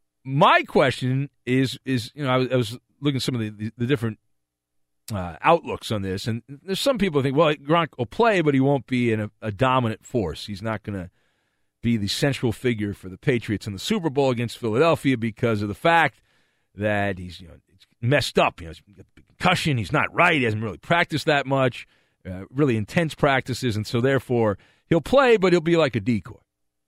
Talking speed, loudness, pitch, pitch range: 210 wpm, -22 LUFS, 120 Hz, 105-145 Hz